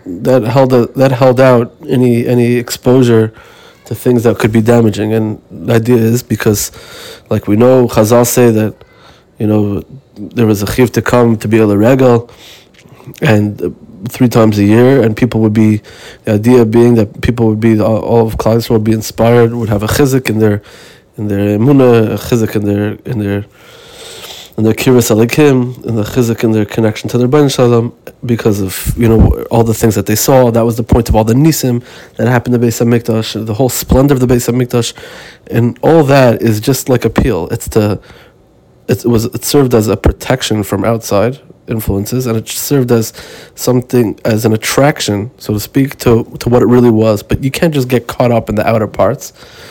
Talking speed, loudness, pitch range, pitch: 200 wpm, -11 LUFS, 110-125 Hz, 115 Hz